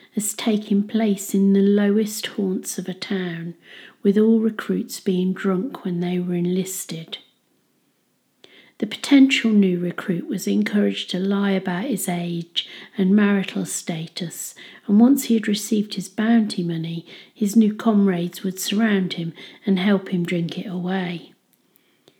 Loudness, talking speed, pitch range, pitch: -21 LUFS, 140 wpm, 180-210 Hz, 195 Hz